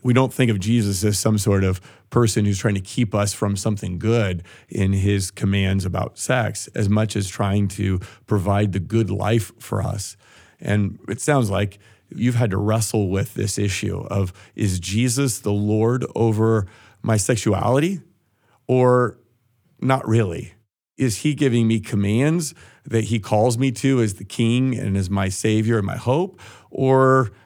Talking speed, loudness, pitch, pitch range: 170 wpm, -21 LUFS, 110 Hz, 100-120 Hz